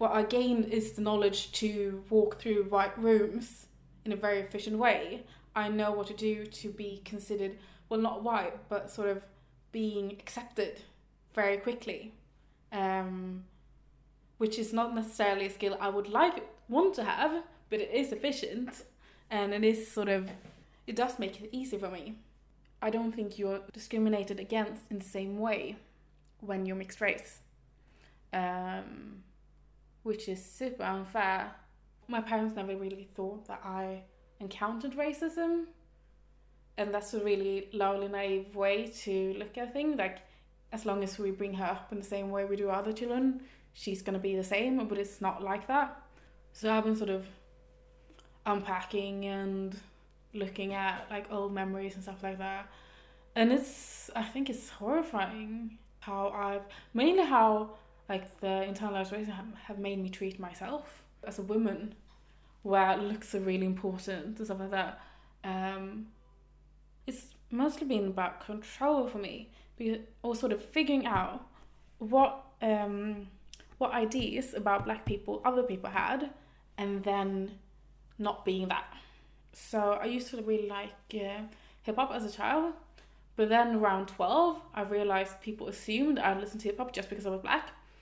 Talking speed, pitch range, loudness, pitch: 160 wpm, 195-230 Hz, -33 LUFS, 205 Hz